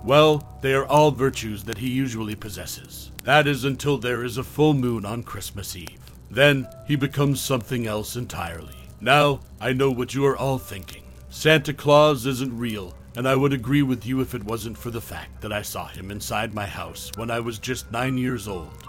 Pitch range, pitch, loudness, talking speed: 105-135 Hz, 125 Hz, -23 LUFS, 205 wpm